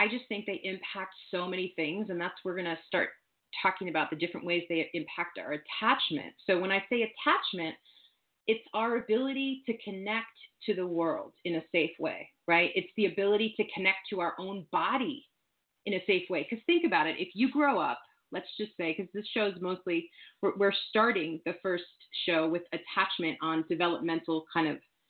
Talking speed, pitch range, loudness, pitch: 190 wpm, 170-215 Hz, -31 LUFS, 190 Hz